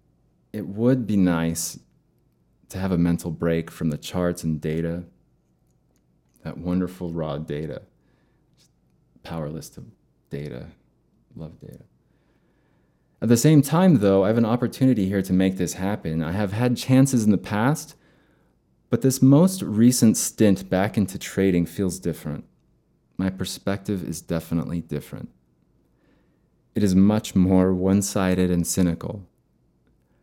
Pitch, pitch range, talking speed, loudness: 95 Hz, 80-105 Hz, 135 wpm, -22 LUFS